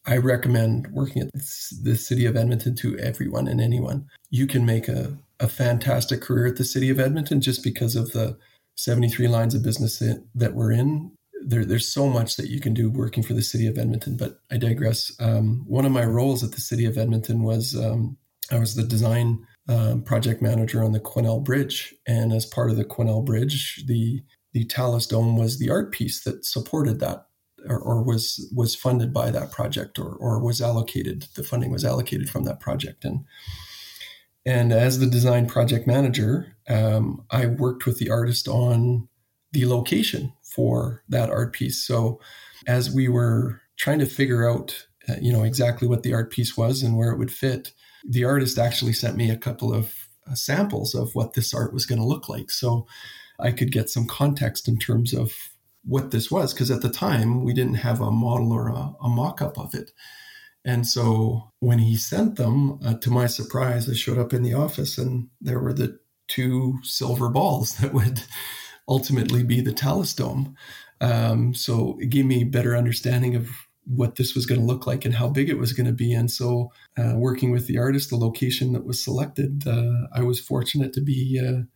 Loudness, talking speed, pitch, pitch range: -23 LUFS, 200 wpm, 120 Hz, 115-130 Hz